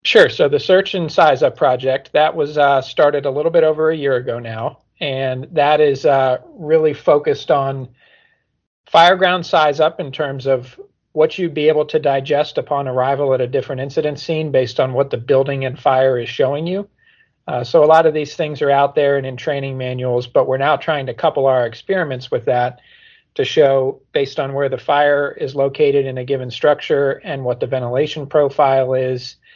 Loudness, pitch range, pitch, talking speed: -16 LUFS, 130-155 Hz, 140 Hz, 205 wpm